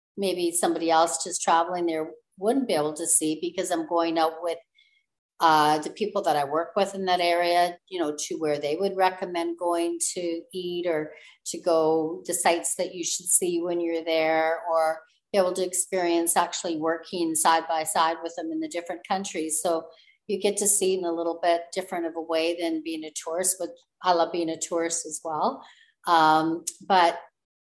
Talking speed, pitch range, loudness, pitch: 200 wpm, 160-180 Hz, -25 LUFS, 170 Hz